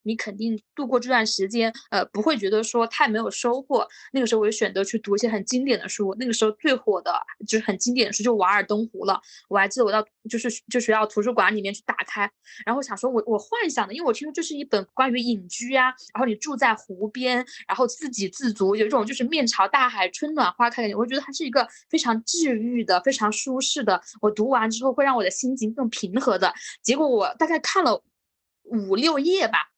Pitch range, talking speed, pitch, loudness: 215-260 Hz, 340 characters per minute, 235 Hz, -23 LUFS